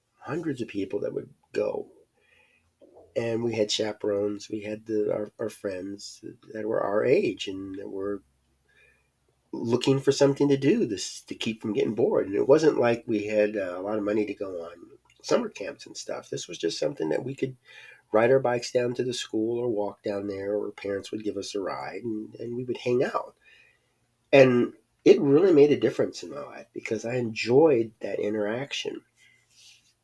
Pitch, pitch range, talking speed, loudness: 110 Hz, 105-125 Hz, 190 wpm, -26 LUFS